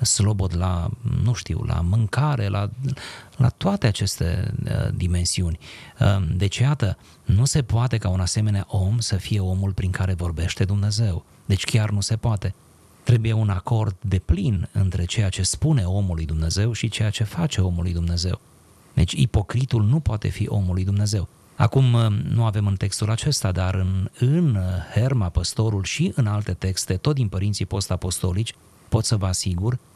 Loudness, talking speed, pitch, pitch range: -23 LUFS, 165 wpm, 105 Hz, 95-115 Hz